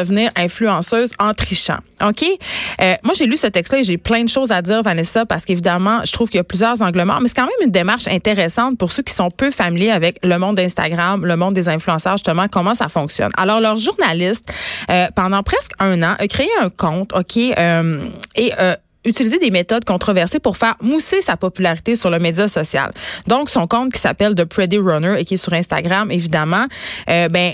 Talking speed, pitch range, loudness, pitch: 215 wpm, 175-230 Hz, -16 LUFS, 195 Hz